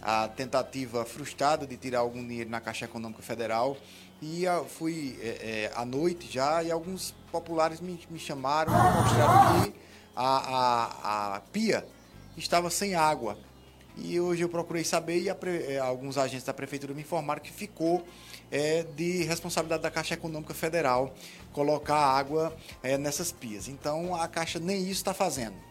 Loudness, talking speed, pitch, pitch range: -29 LUFS, 165 wpm, 150 Hz, 120-170 Hz